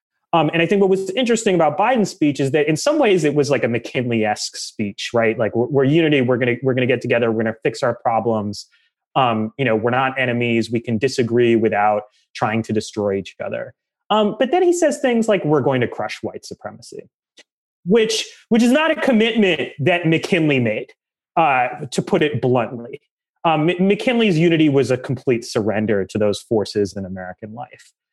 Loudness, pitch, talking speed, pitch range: -18 LUFS, 135 Hz, 205 wpm, 115-190 Hz